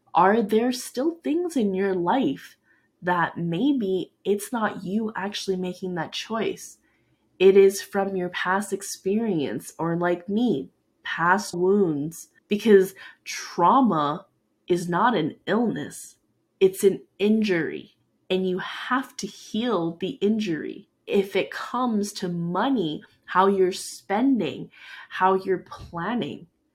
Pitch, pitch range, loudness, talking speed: 195 Hz, 180-220 Hz, -24 LUFS, 120 wpm